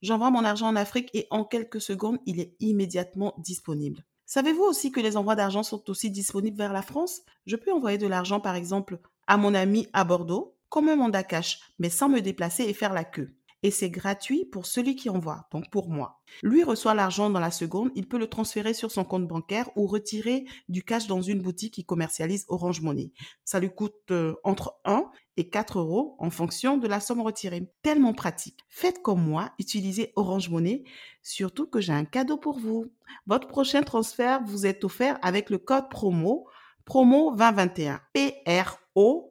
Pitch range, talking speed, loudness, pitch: 185-235 Hz, 190 wpm, -27 LUFS, 205 Hz